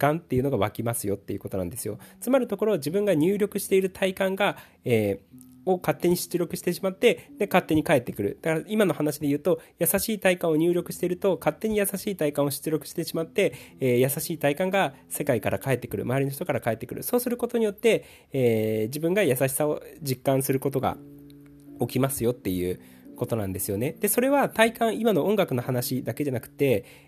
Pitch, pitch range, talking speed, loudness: 150 Hz, 125-190 Hz, 430 characters per minute, -26 LUFS